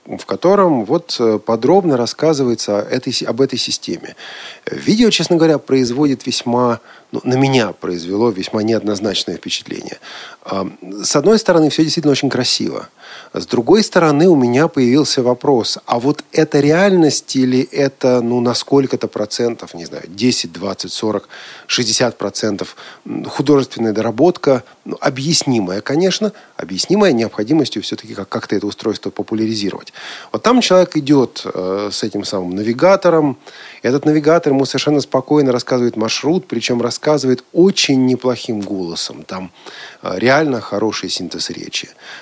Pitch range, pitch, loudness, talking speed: 110-150 Hz, 125 Hz, -15 LUFS, 130 wpm